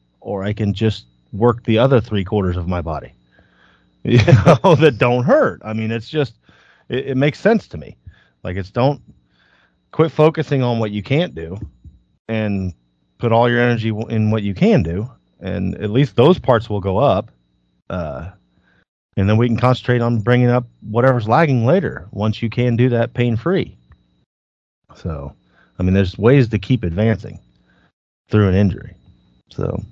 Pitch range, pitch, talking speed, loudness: 90-125 Hz, 110 Hz, 170 wpm, -17 LUFS